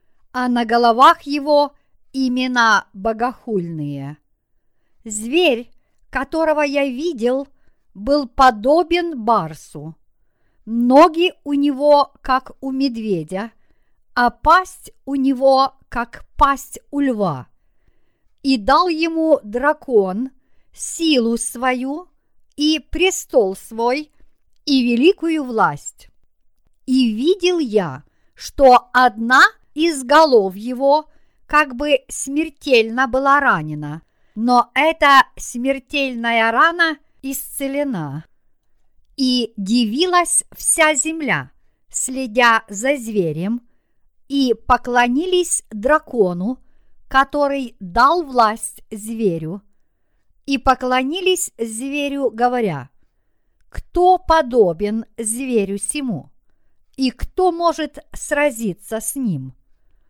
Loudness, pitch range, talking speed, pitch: -17 LUFS, 225-290 Hz, 85 wpm, 260 Hz